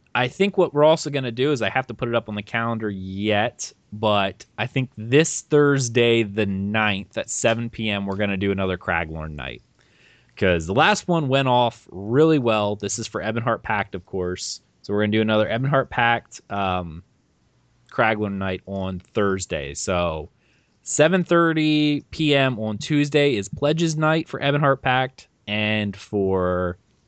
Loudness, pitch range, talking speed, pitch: -22 LUFS, 100-135 Hz, 170 wpm, 110 Hz